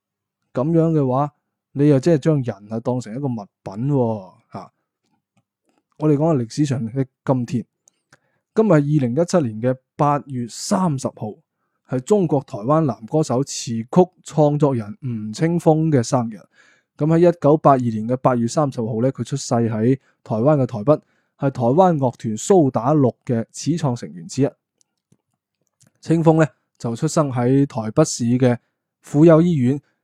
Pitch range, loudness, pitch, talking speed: 120-155 Hz, -19 LUFS, 140 Hz, 230 characters per minute